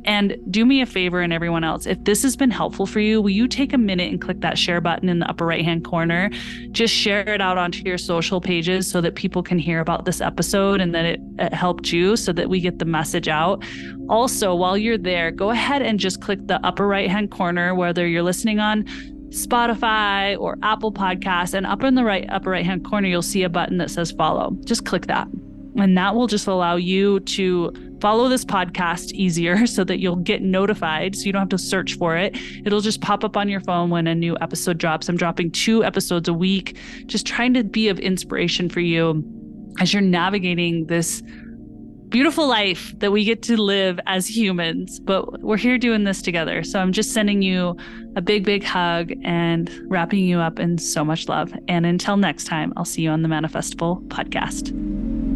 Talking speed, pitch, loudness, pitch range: 215 wpm, 190 Hz, -20 LUFS, 175-215 Hz